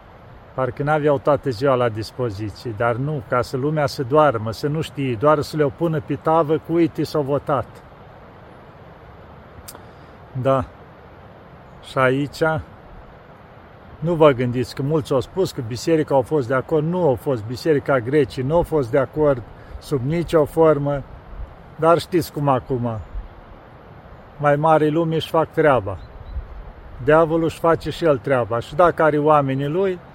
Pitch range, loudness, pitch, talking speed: 125-155 Hz, -20 LUFS, 140 Hz, 155 wpm